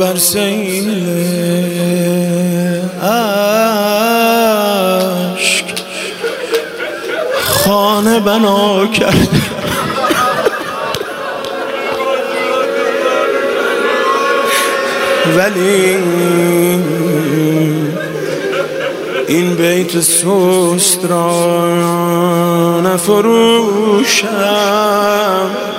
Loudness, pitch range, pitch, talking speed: -12 LUFS, 175-210 Hz, 190 Hz, 30 wpm